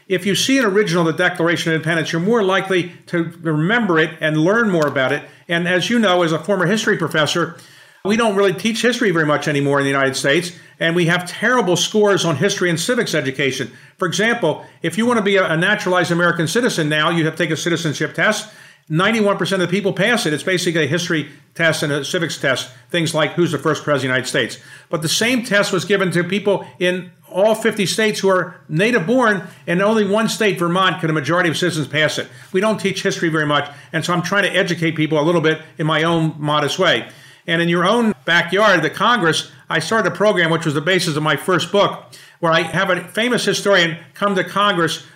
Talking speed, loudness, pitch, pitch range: 230 wpm, -17 LUFS, 175 Hz, 155-195 Hz